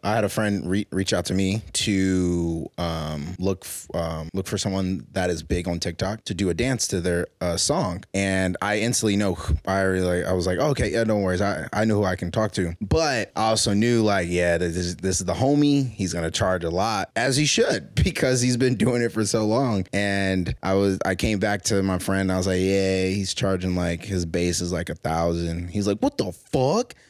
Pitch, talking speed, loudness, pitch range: 95 Hz, 240 wpm, -23 LUFS, 90-105 Hz